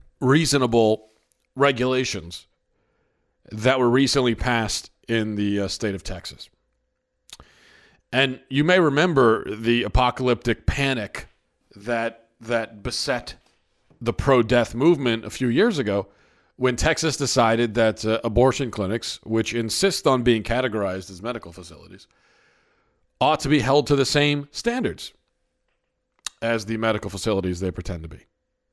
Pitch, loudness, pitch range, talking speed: 115 Hz, -22 LUFS, 105-130 Hz, 125 wpm